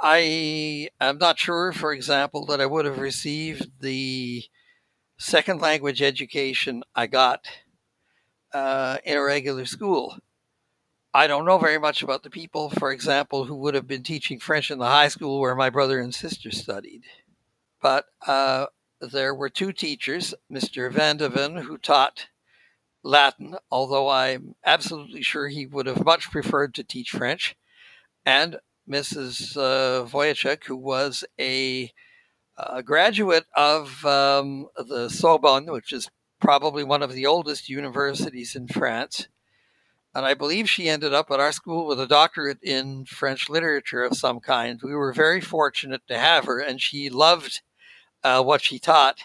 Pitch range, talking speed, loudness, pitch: 135-155 Hz, 155 wpm, -22 LUFS, 140 Hz